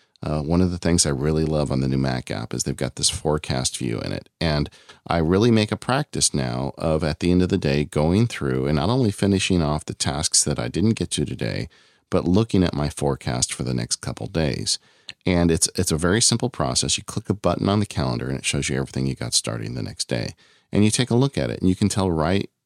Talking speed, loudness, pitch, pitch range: 260 wpm, -22 LUFS, 85 Hz, 70-100 Hz